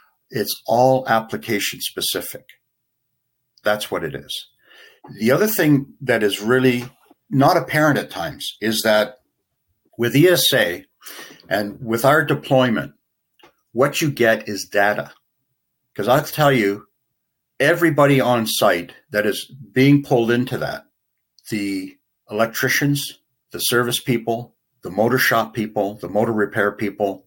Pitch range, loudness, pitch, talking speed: 105-135 Hz, -19 LUFS, 125 Hz, 125 wpm